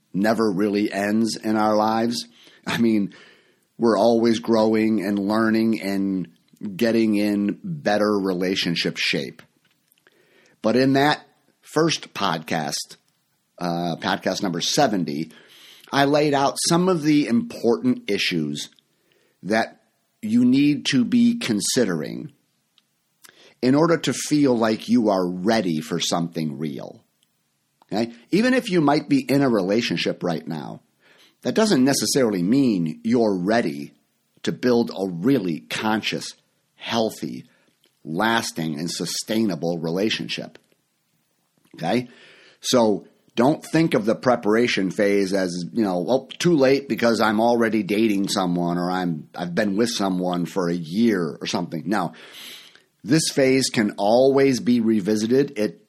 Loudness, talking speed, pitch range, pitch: -21 LUFS, 130 wpm, 95-130 Hz, 110 Hz